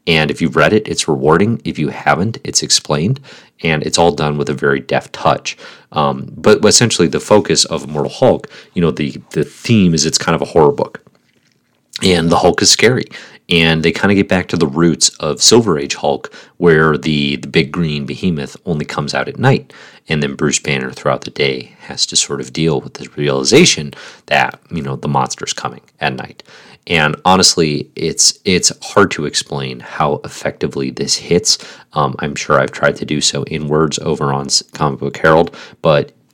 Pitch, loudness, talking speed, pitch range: 75 Hz, -14 LUFS, 200 wpm, 70-85 Hz